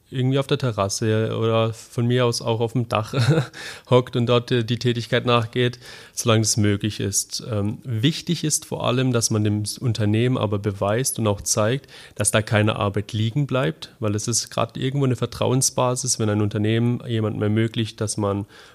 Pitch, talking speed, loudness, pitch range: 115 Hz, 180 wpm, -22 LUFS, 105-125 Hz